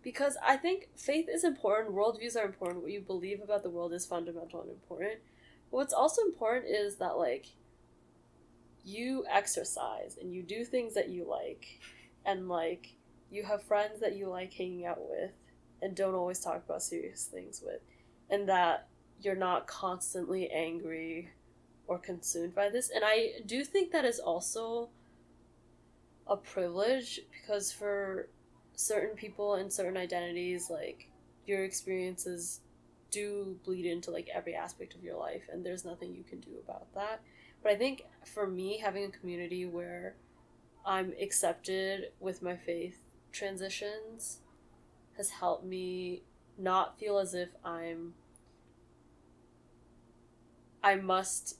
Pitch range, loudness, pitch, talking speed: 175-210 Hz, -35 LUFS, 190 Hz, 145 wpm